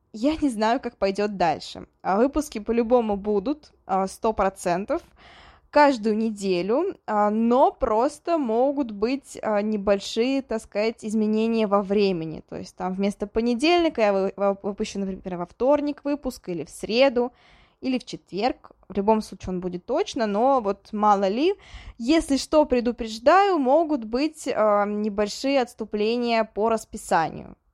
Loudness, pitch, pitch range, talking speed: -24 LUFS, 225 Hz, 205-270 Hz, 130 wpm